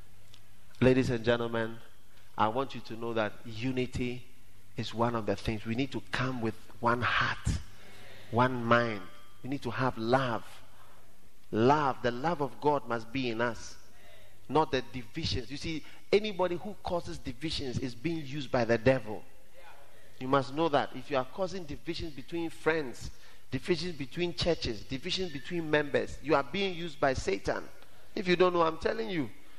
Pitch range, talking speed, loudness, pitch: 110-145 Hz, 170 wpm, -32 LUFS, 125 Hz